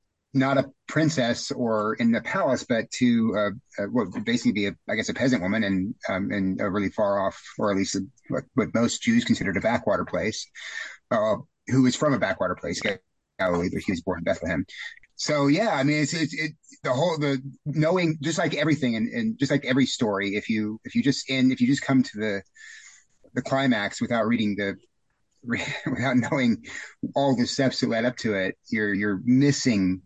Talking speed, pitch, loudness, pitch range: 205 wpm, 135 Hz, -25 LUFS, 110-155 Hz